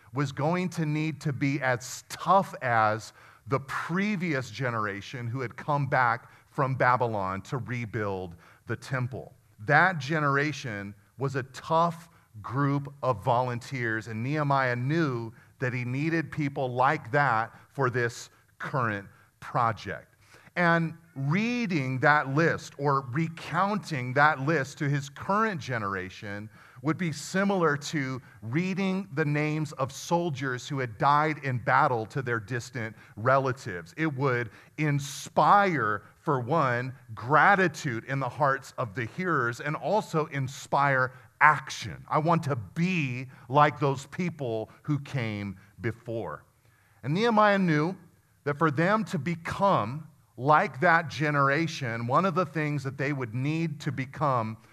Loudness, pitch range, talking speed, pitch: -28 LUFS, 120-155 Hz, 130 wpm, 140 Hz